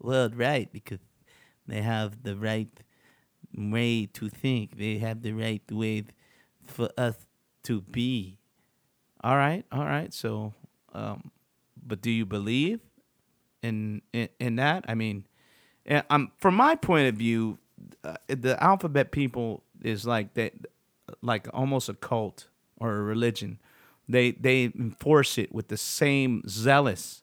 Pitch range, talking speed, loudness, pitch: 110-130 Hz, 140 wpm, -28 LUFS, 115 Hz